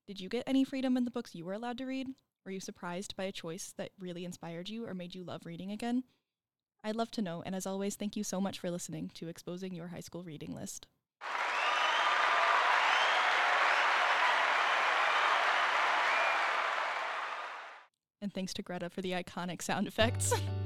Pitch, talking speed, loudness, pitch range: 190 Hz, 170 wpm, -32 LUFS, 175-215 Hz